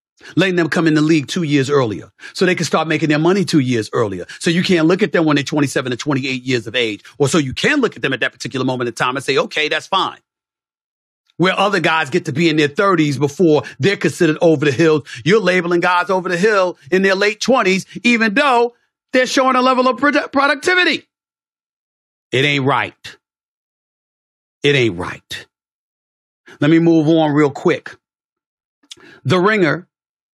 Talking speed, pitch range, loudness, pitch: 200 wpm, 145-190 Hz, -15 LUFS, 165 Hz